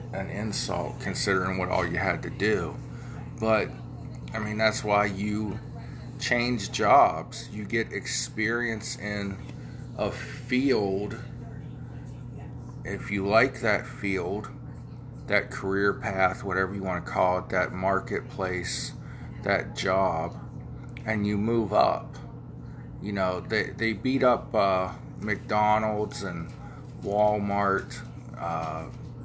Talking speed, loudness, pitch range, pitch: 115 wpm, -27 LUFS, 95-115 Hz, 105 Hz